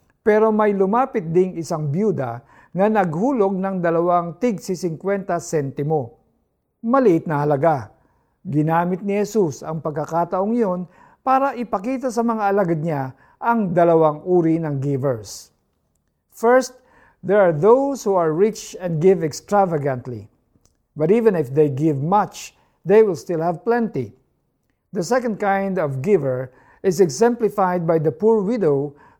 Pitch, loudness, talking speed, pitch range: 180 Hz, -20 LUFS, 135 wpm, 155-210 Hz